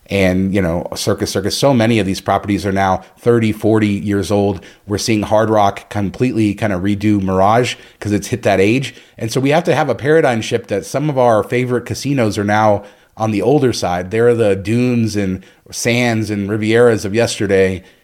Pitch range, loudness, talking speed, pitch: 100-120 Hz, -15 LUFS, 200 wpm, 105 Hz